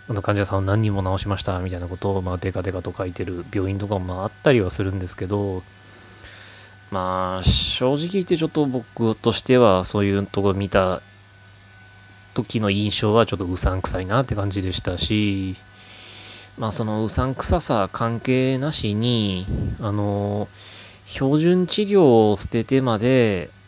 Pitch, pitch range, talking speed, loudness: 100 Hz, 95-115 Hz, 305 characters per minute, -20 LUFS